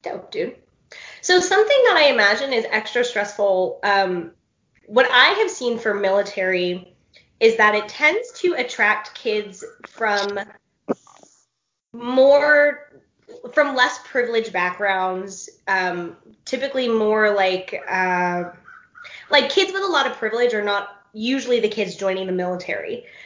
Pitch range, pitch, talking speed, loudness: 195-280 Hz, 220 Hz, 130 wpm, -19 LUFS